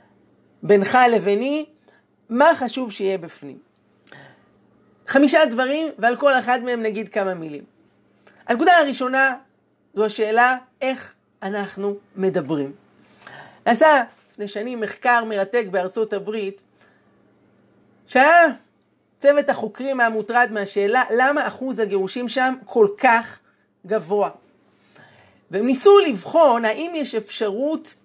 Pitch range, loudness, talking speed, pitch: 205-265 Hz, -19 LUFS, 100 wpm, 235 Hz